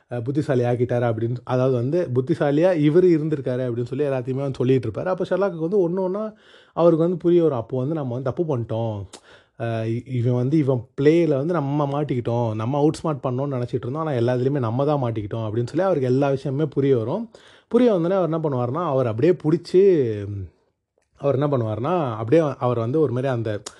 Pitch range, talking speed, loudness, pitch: 125-165 Hz, 175 wpm, -22 LUFS, 140 Hz